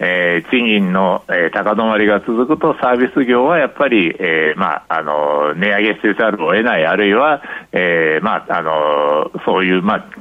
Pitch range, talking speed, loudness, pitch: 85-120 Hz, 345 characters per minute, -14 LUFS, 100 Hz